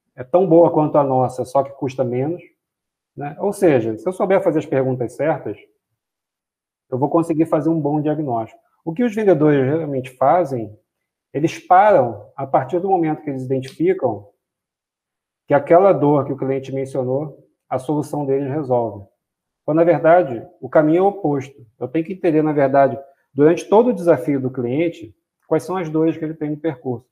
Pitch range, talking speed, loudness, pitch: 130-165 Hz, 180 wpm, -18 LUFS, 150 Hz